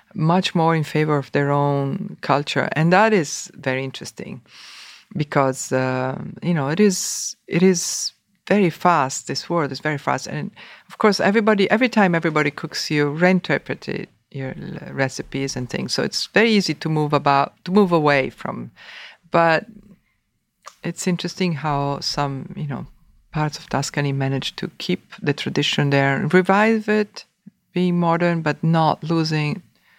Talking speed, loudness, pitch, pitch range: 155 wpm, -20 LUFS, 160 Hz, 140-185 Hz